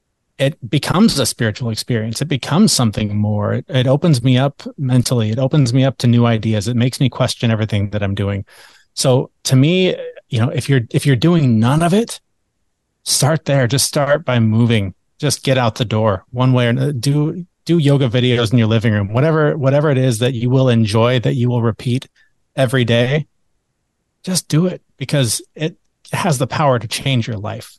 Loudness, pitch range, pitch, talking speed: -16 LUFS, 115-145 Hz, 130 Hz, 200 wpm